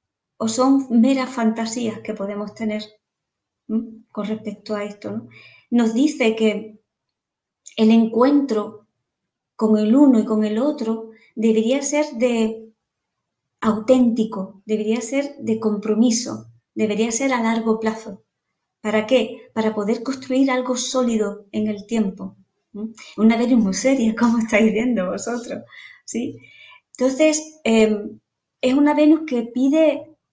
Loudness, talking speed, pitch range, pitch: -20 LUFS, 130 wpm, 215-255 Hz, 225 Hz